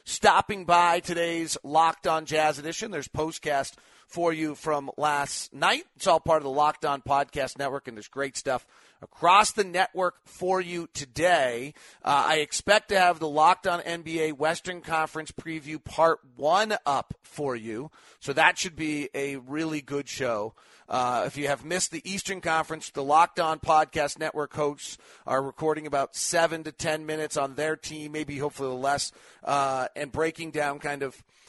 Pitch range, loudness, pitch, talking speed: 140-165 Hz, -26 LUFS, 155 Hz, 175 wpm